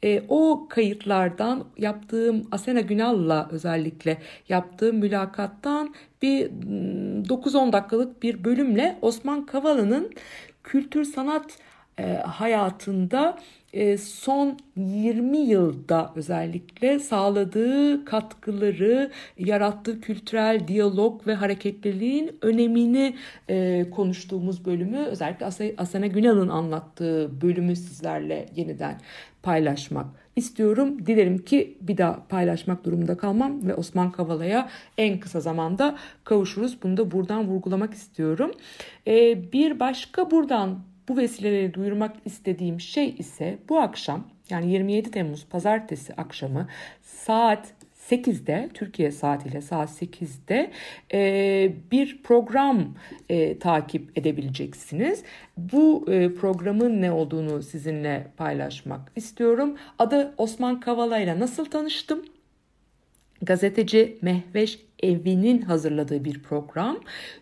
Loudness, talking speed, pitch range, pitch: -25 LUFS, 95 wpm, 175-240 Hz, 205 Hz